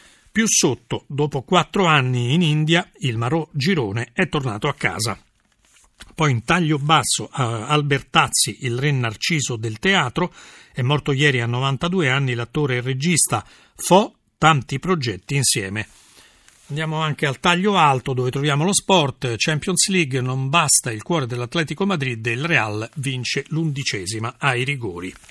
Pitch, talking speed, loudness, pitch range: 140 Hz, 145 wpm, -20 LUFS, 125-165 Hz